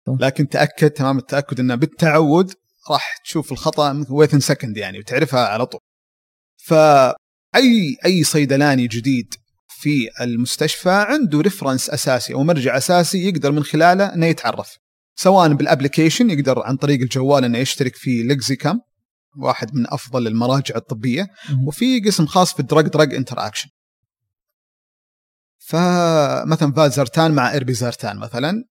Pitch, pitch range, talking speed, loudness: 145 Hz, 130-160 Hz, 125 wpm, -17 LUFS